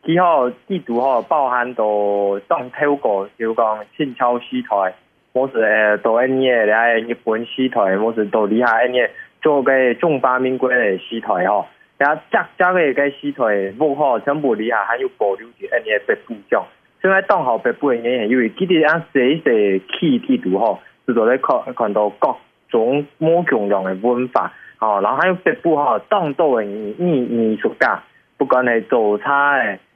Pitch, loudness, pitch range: 125 Hz, -17 LUFS, 110-155 Hz